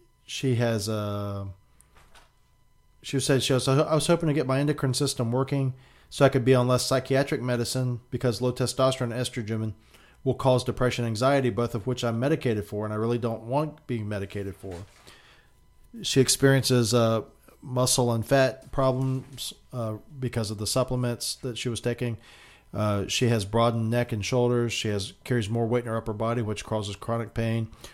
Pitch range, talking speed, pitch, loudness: 115-130 Hz, 180 wpm, 120 Hz, -26 LUFS